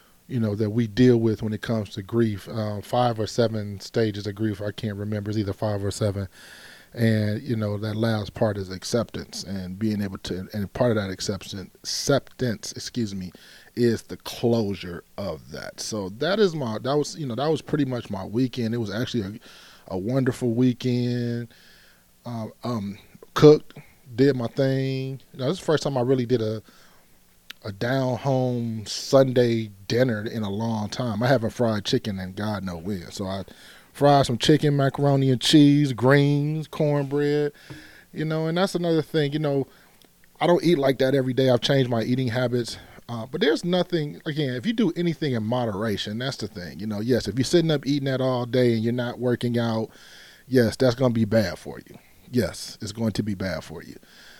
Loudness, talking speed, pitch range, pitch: -24 LUFS, 200 wpm, 105-135 Hz, 120 Hz